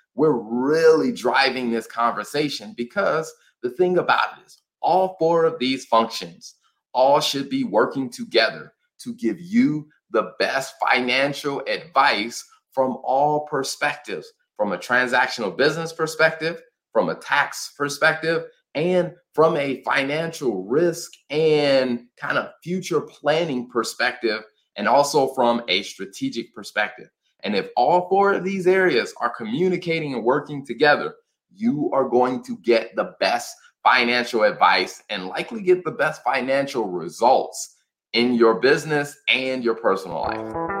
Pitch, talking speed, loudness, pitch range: 155 Hz, 135 wpm, -21 LUFS, 130-200 Hz